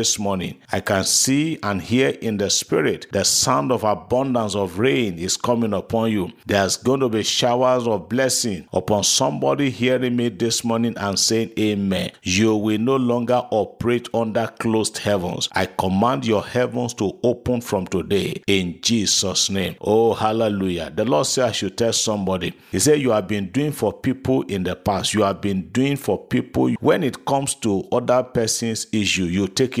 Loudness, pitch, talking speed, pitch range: -20 LUFS, 110 Hz, 185 wpm, 100-125 Hz